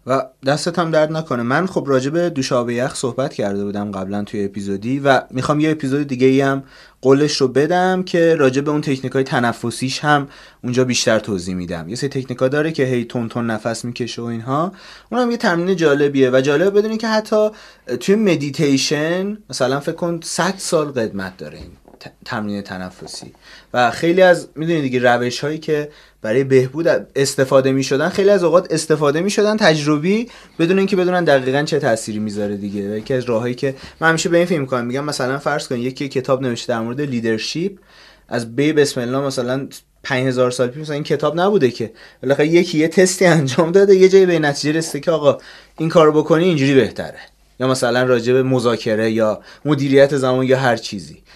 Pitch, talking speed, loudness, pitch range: 140 Hz, 190 wpm, -17 LUFS, 125-165 Hz